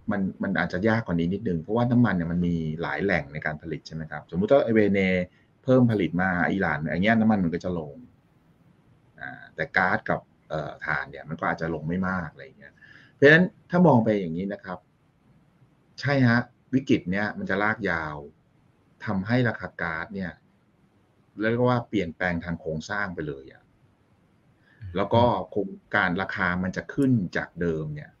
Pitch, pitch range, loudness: 100 Hz, 85-120 Hz, -25 LUFS